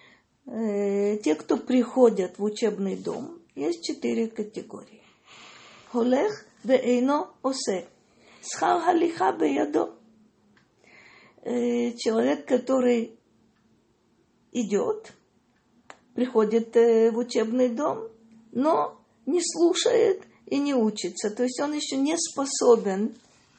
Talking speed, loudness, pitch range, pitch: 80 wpm, -25 LUFS, 225-285 Hz, 240 Hz